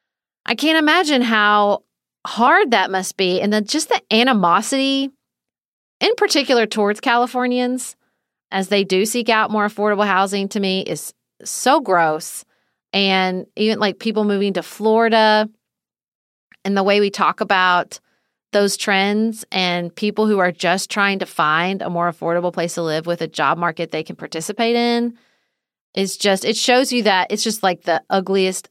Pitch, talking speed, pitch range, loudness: 205 Hz, 165 wpm, 185-225 Hz, -18 LUFS